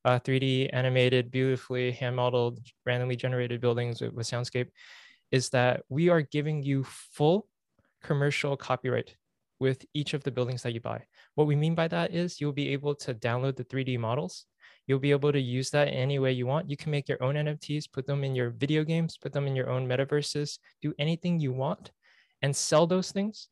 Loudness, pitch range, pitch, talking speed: -29 LUFS, 125-150 Hz, 135 Hz, 200 wpm